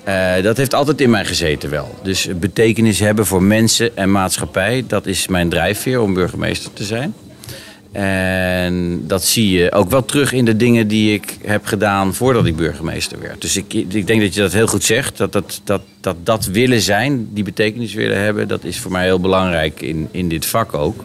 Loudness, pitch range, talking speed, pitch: -16 LUFS, 95-110 Hz, 210 wpm, 100 Hz